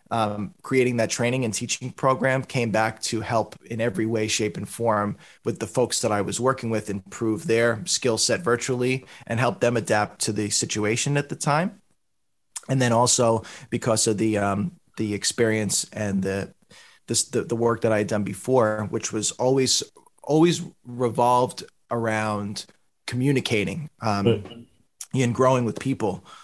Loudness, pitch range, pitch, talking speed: -24 LUFS, 110-130 Hz, 115 Hz, 165 wpm